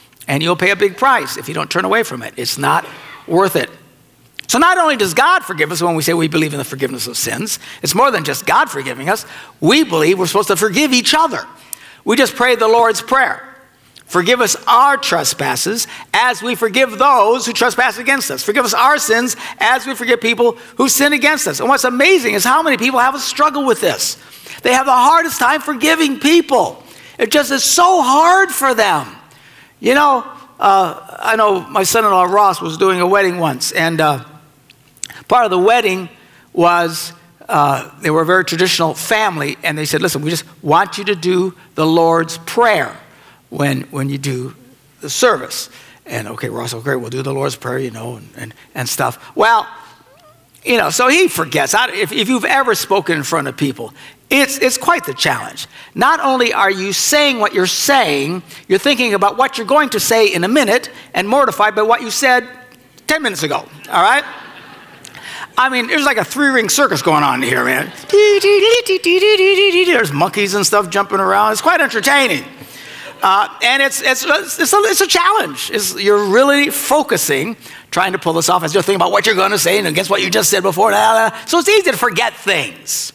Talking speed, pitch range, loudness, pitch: 205 wpm, 170-275 Hz, -13 LUFS, 225 Hz